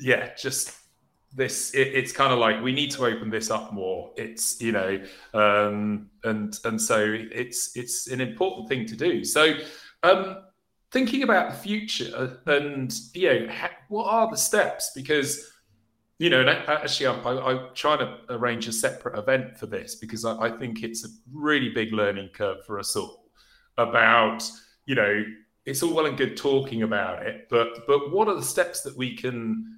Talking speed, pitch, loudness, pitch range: 185 wpm, 125 Hz, -25 LUFS, 110-145 Hz